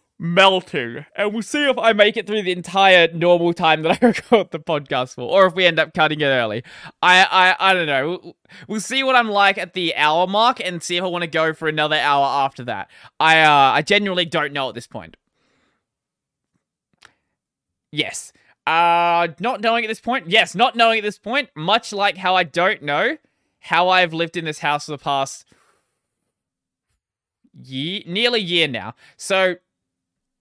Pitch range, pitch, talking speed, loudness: 155-200 Hz, 175 Hz, 190 wpm, -17 LUFS